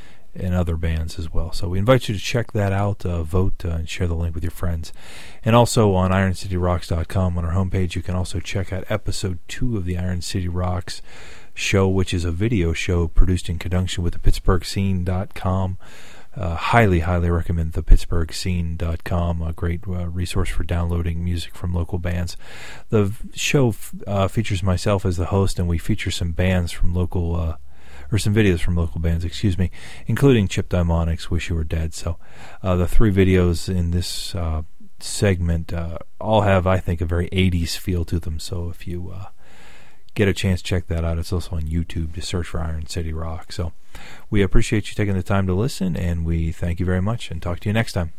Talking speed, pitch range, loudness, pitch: 205 wpm, 85-95 Hz, -22 LUFS, 90 Hz